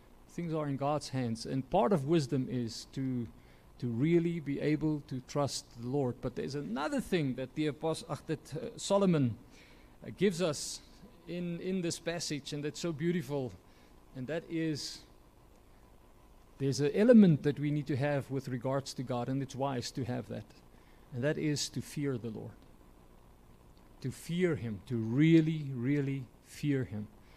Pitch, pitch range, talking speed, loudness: 135 Hz, 115-155 Hz, 170 wpm, -33 LUFS